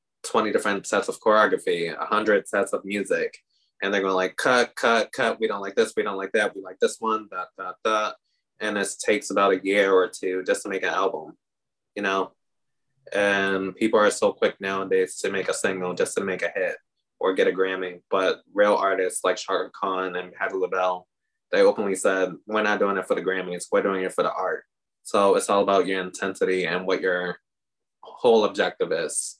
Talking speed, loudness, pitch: 210 wpm, -24 LUFS, 110 Hz